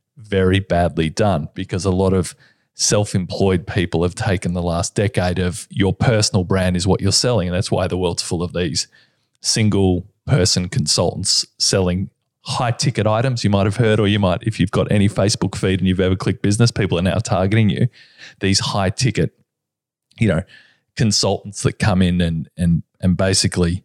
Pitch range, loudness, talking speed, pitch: 90-110 Hz, -18 LUFS, 185 wpm, 95 Hz